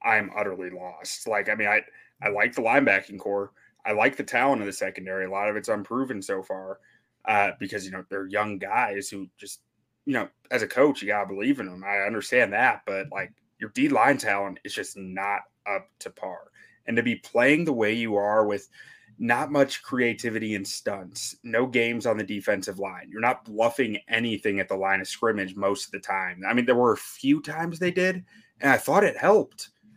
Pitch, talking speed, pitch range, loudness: 105 Hz, 215 wpm, 100-125 Hz, -25 LUFS